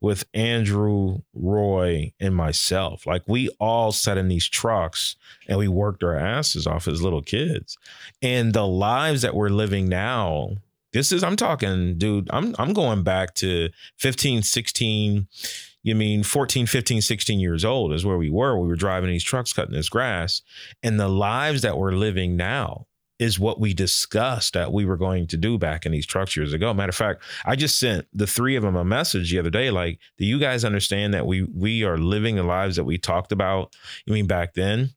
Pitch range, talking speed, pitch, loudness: 90-115 Hz, 200 wpm, 100 Hz, -23 LUFS